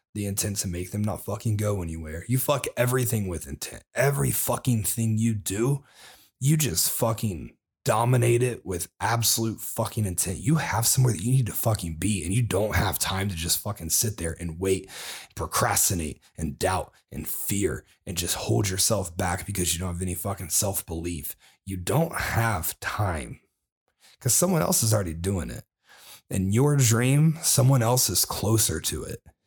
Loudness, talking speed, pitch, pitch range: -25 LUFS, 175 wpm, 105 Hz, 90-120 Hz